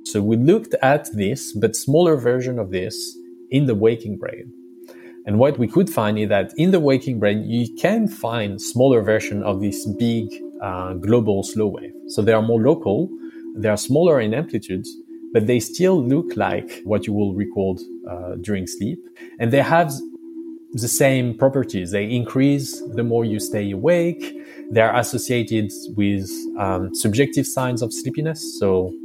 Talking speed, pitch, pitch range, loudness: 170 wpm, 115 Hz, 100-140 Hz, -20 LUFS